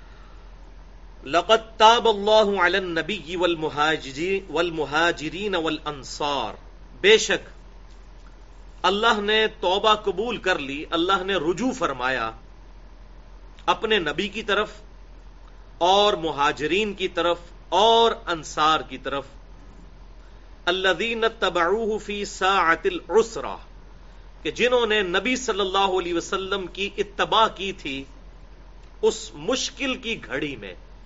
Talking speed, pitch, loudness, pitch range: 100 wpm, 190 Hz, -22 LUFS, 160-215 Hz